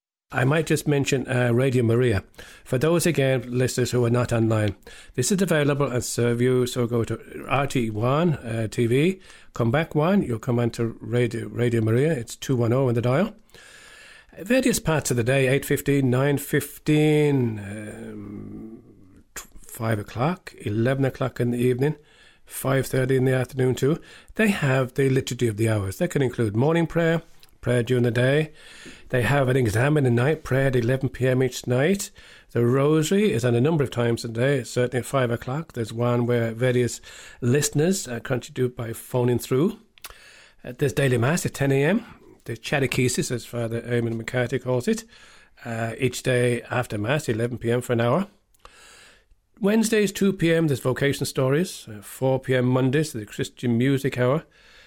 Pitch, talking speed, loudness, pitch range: 130 Hz, 170 wpm, -23 LUFS, 120-145 Hz